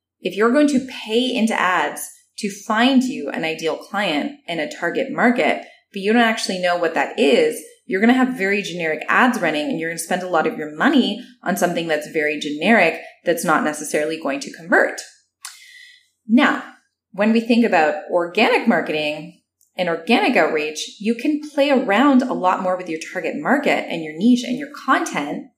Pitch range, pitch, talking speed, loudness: 165-255 Hz, 220 Hz, 190 wpm, -19 LUFS